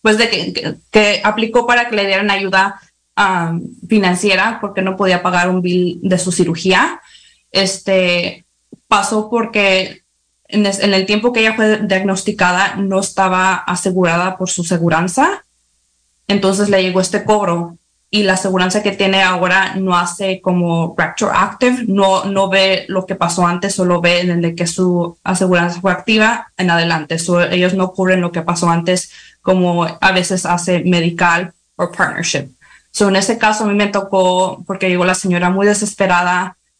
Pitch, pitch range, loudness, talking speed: 185 Hz, 175-200 Hz, -14 LUFS, 165 wpm